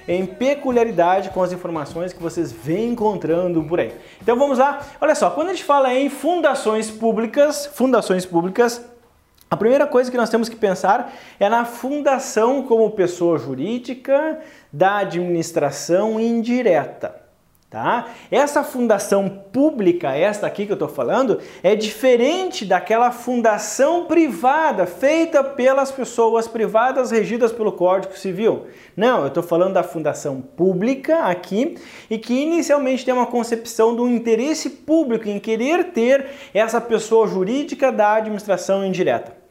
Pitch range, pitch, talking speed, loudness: 190-270 Hz, 230 Hz, 135 wpm, -19 LUFS